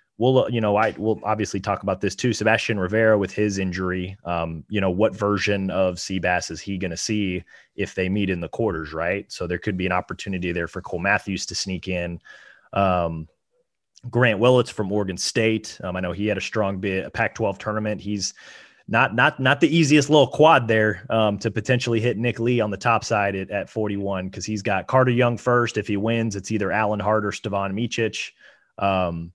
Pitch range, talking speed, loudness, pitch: 95-115 Hz, 215 wpm, -22 LUFS, 105 Hz